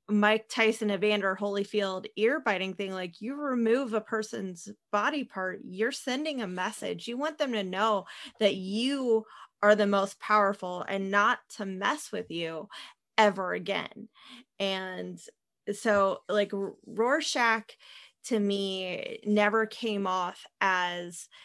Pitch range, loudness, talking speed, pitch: 195-225 Hz, -29 LUFS, 130 wpm, 210 Hz